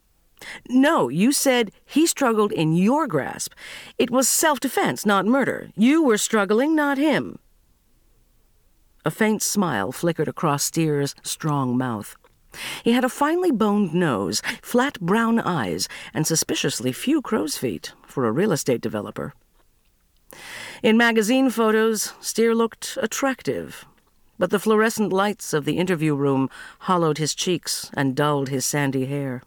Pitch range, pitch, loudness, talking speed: 155-250 Hz, 210 Hz, -21 LUFS, 140 wpm